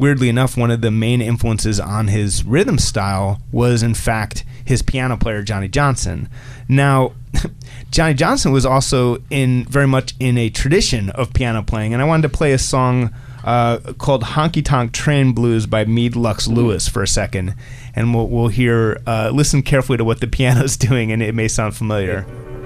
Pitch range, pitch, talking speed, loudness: 110-130 Hz, 120 Hz, 185 wpm, -17 LUFS